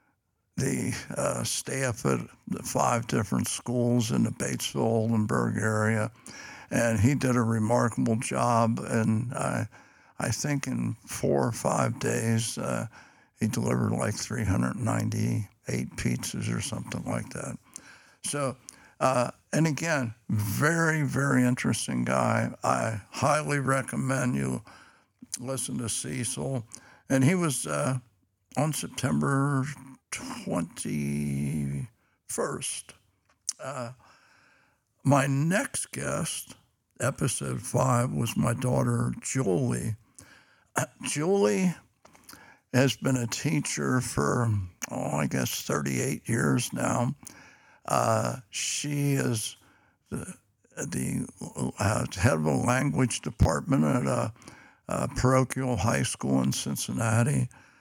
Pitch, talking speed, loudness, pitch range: 120 Hz, 105 wpm, -28 LUFS, 110-135 Hz